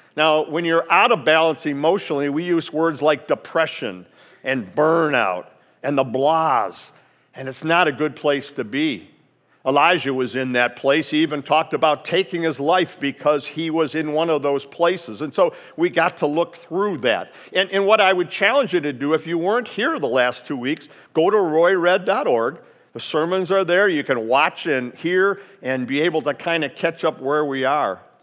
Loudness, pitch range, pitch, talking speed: -20 LUFS, 145-175 Hz, 160 Hz, 200 wpm